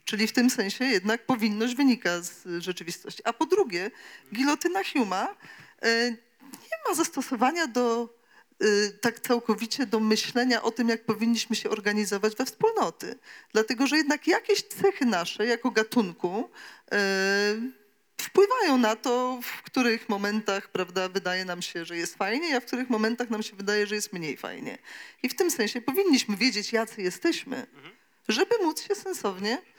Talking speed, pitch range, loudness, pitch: 150 wpm, 210-265 Hz, -27 LUFS, 230 Hz